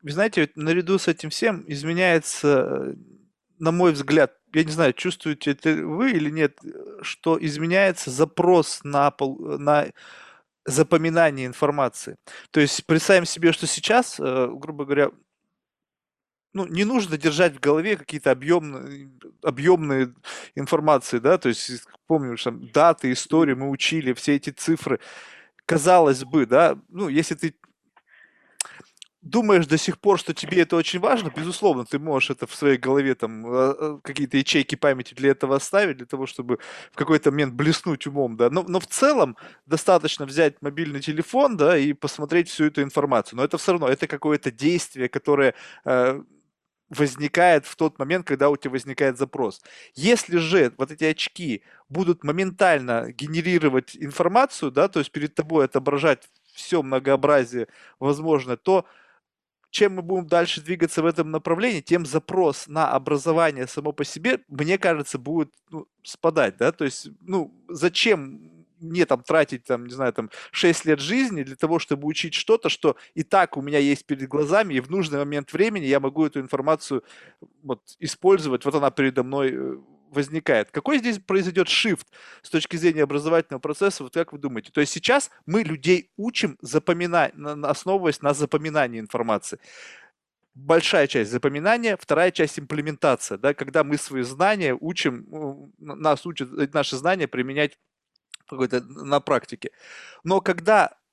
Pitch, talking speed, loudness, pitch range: 155 Hz, 150 wpm, -22 LUFS, 140-175 Hz